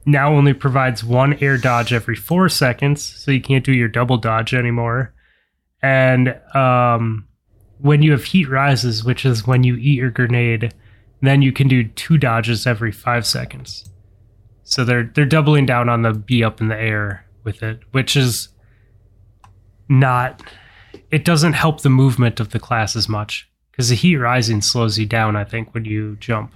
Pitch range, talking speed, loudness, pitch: 110-135 Hz, 180 wpm, -16 LUFS, 120 Hz